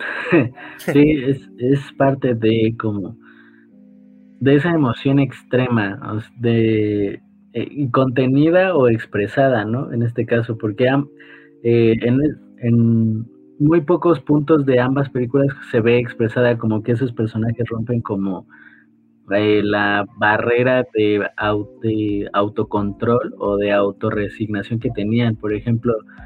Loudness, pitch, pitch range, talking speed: -18 LUFS, 115 Hz, 105-135 Hz, 120 wpm